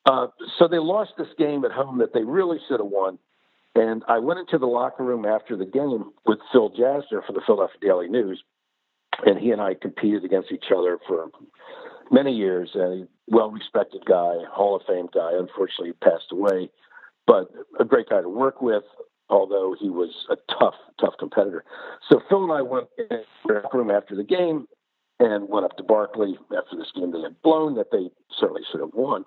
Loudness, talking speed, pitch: -23 LUFS, 200 wpm, 170 Hz